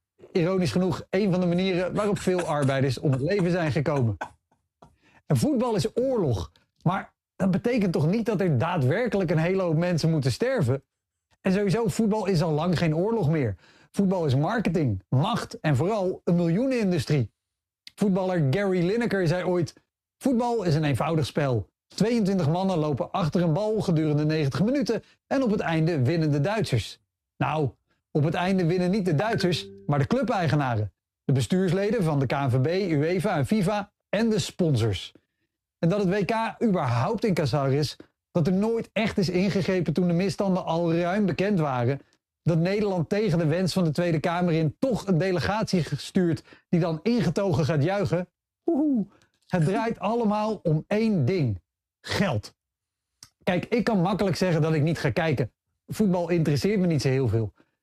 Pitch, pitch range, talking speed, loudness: 175 Hz, 150-200 Hz, 170 wpm, -25 LUFS